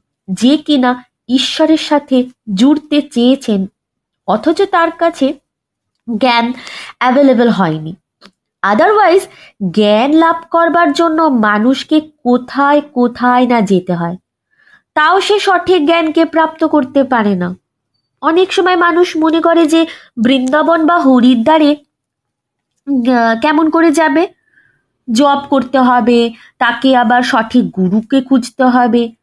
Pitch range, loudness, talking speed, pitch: 240-325 Hz, -11 LUFS, 105 wpm, 270 Hz